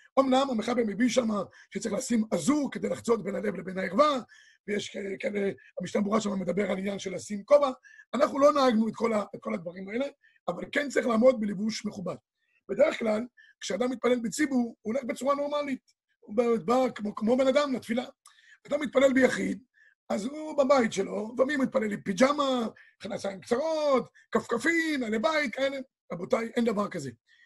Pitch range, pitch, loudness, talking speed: 210-275 Hz, 245 Hz, -28 LUFS, 175 wpm